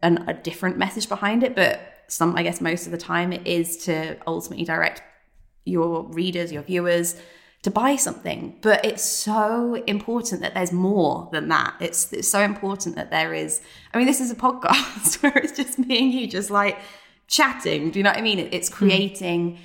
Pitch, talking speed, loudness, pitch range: 195 Hz, 200 wpm, -22 LUFS, 170-215 Hz